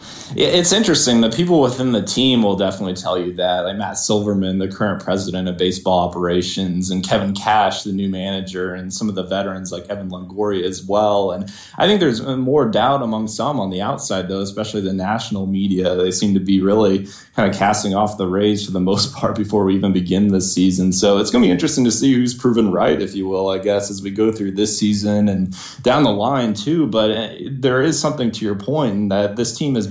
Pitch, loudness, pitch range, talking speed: 100 Hz, -18 LUFS, 95-110 Hz, 225 wpm